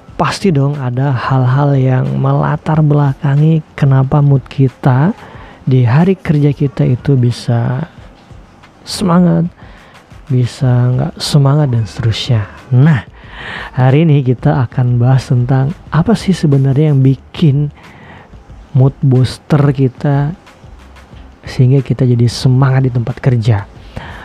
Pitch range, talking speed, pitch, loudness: 125-150 Hz, 110 wpm, 135 Hz, -12 LUFS